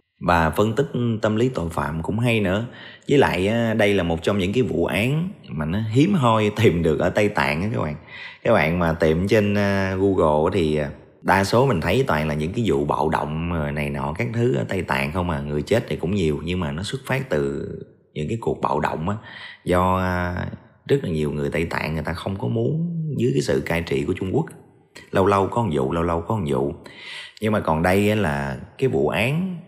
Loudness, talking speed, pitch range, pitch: -22 LUFS, 230 wpm, 80-115 Hz, 95 Hz